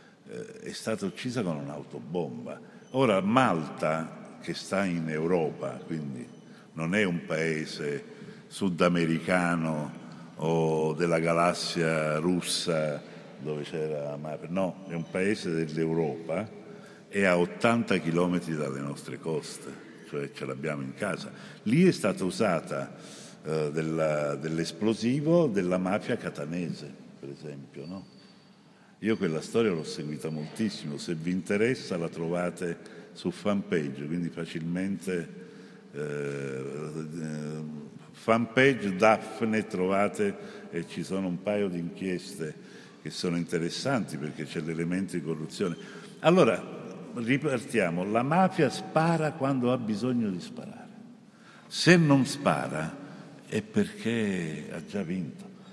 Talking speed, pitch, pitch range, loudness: 115 wpm, 85 Hz, 80-110 Hz, -29 LUFS